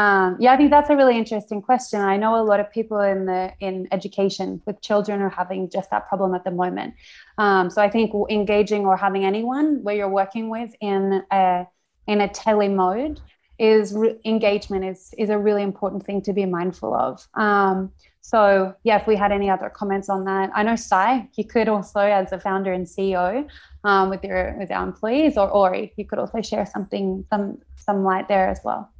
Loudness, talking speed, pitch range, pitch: -21 LUFS, 210 wpm, 190-215 Hz, 200 Hz